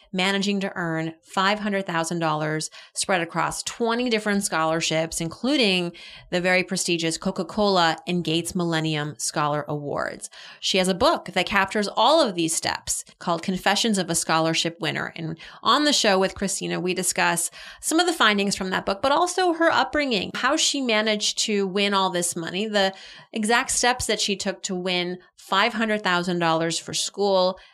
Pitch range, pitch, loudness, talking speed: 170-210 Hz, 190 Hz, -23 LUFS, 160 wpm